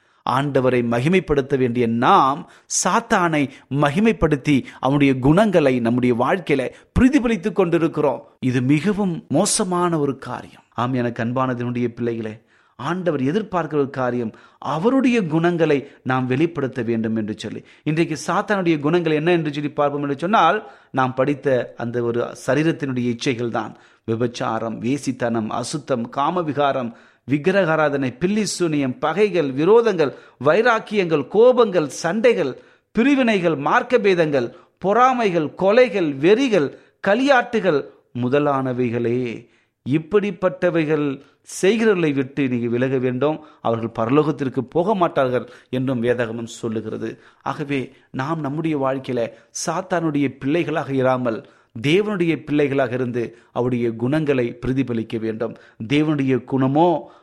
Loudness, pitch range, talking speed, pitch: -20 LUFS, 125-170 Hz, 105 wpm, 145 Hz